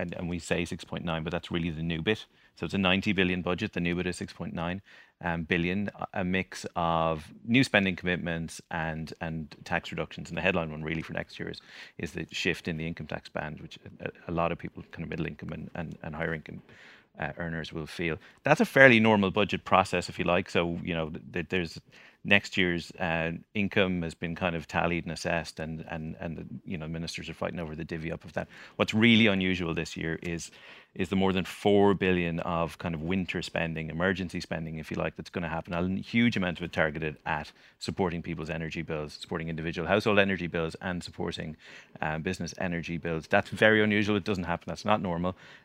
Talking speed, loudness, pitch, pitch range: 220 wpm, -29 LUFS, 85 Hz, 80-95 Hz